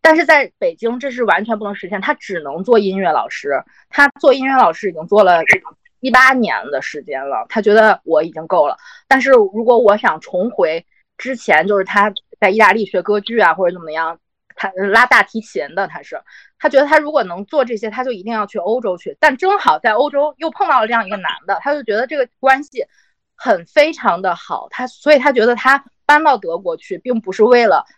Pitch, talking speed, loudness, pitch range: 250 Hz, 310 characters per minute, -14 LUFS, 210-295 Hz